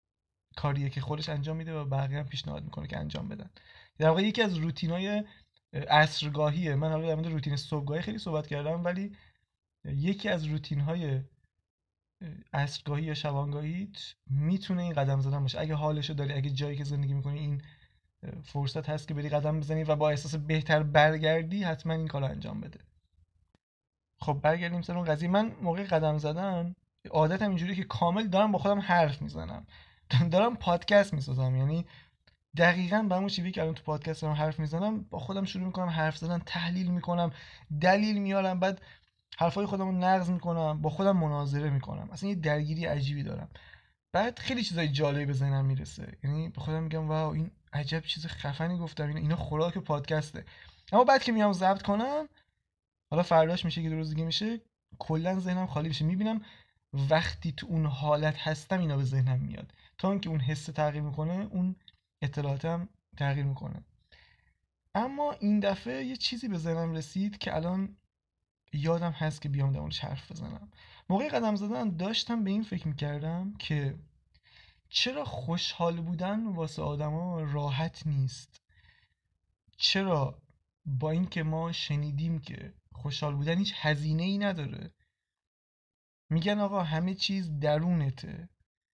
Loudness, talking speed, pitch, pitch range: -31 LUFS, 160 wpm, 155 Hz, 145-180 Hz